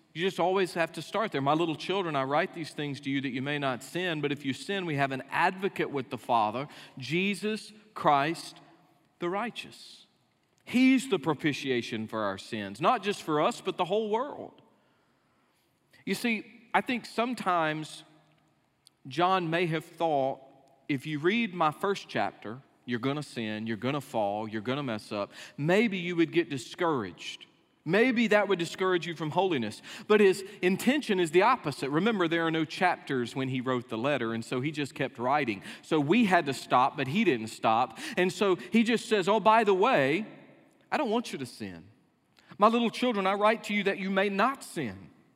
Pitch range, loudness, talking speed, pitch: 135-200 Hz, -29 LUFS, 190 wpm, 170 Hz